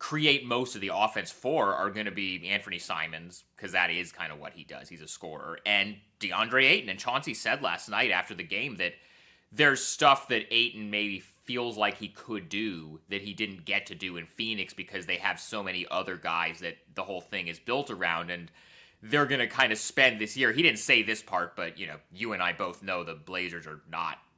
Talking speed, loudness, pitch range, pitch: 230 wpm, -28 LUFS, 90-115 Hz, 100 Hz